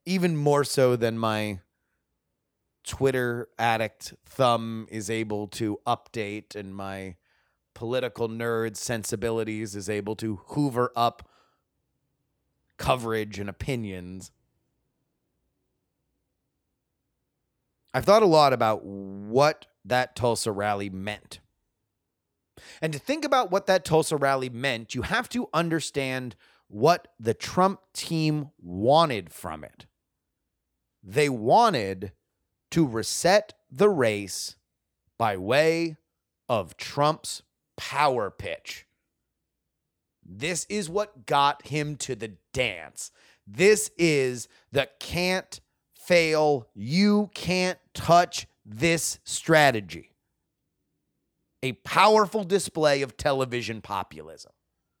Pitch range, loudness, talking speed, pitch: 105-155 Hz, -25 LUFS, 100 wpm, 125 Hz